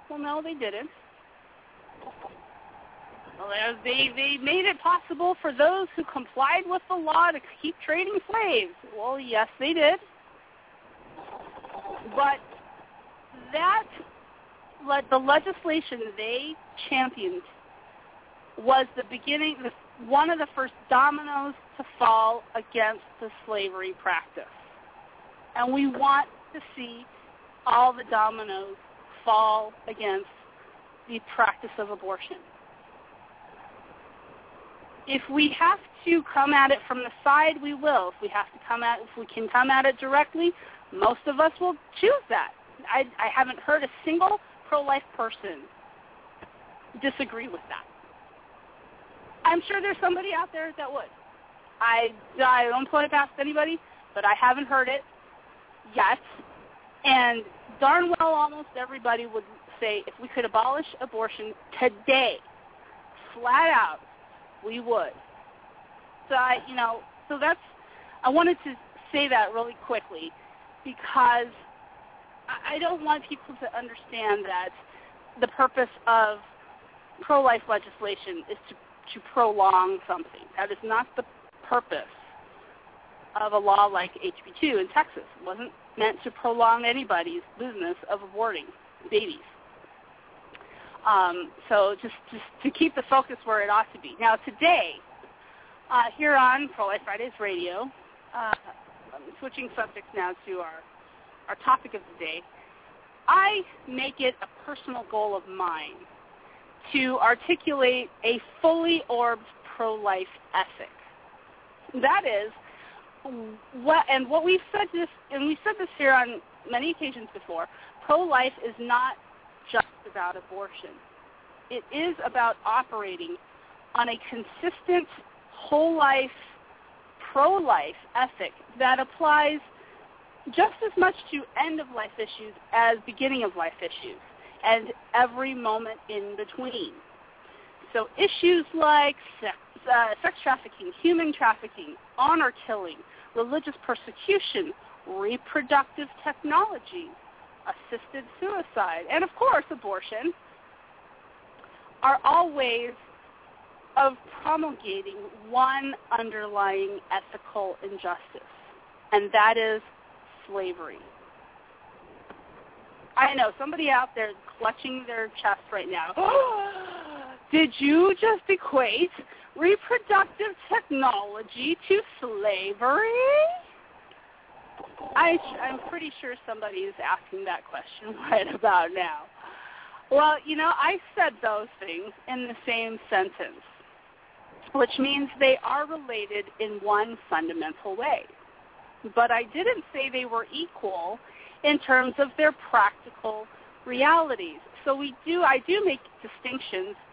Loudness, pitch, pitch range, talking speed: -26 LUFS, 270 Hz, 230-330 Hz, 120 wpm